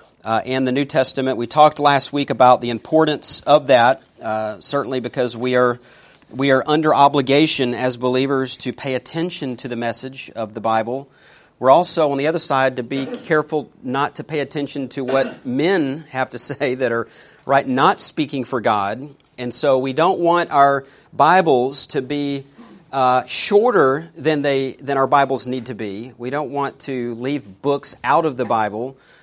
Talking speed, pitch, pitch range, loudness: 190 wpm, 135 Hz, 125-145 Hz, -18 LUFS